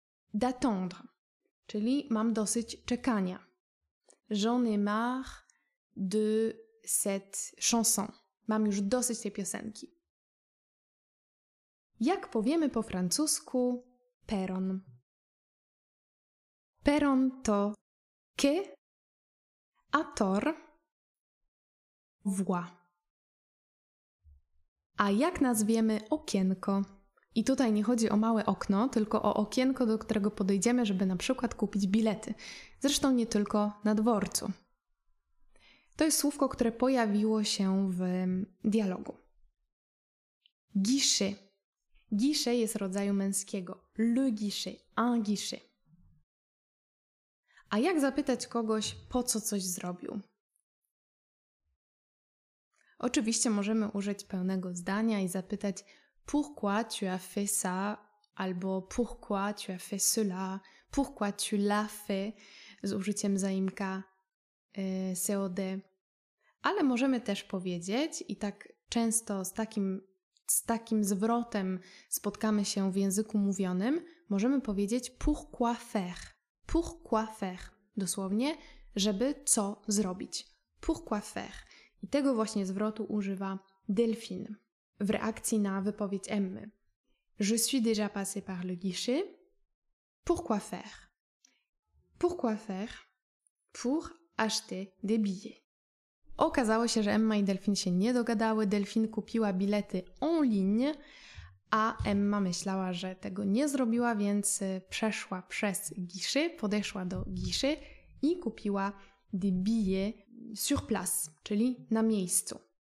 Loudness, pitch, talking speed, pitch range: -32 LUFS, 210 Hz, 105 wpm, 195-235 Hz